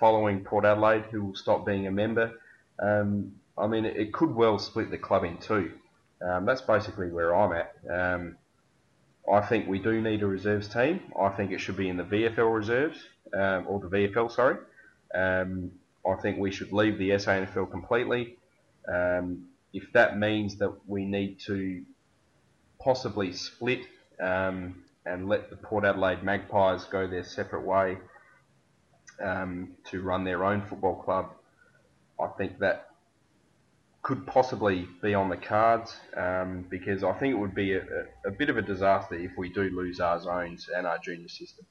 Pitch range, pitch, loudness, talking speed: 95-105 Hz, 100 Hz, -29 LUFS, 170 wpm